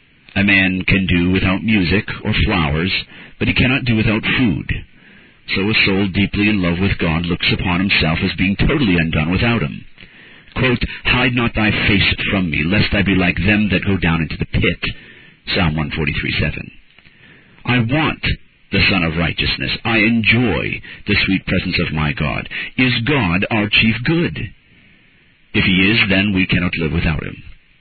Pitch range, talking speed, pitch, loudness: 85-110 Hz, 170 wpm, 95 Hz, -16 LUFS